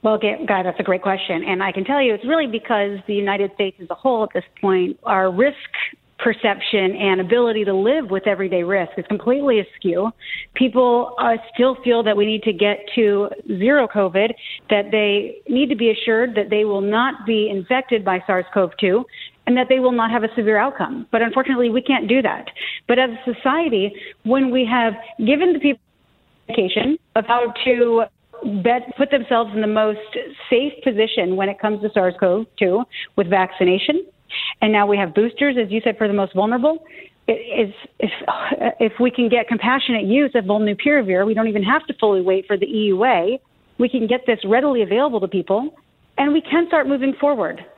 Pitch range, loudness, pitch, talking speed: 205-255 Hz, -19 LUFS, 225 Hz, 190 wpm